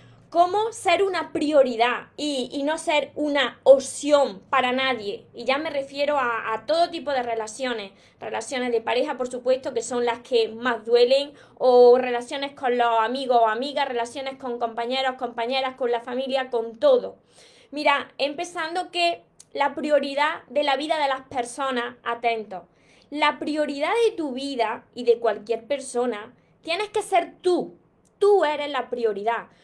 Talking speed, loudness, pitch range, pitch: 160 wpm, -23 LUFS, 240-295 Hz, 265 Hz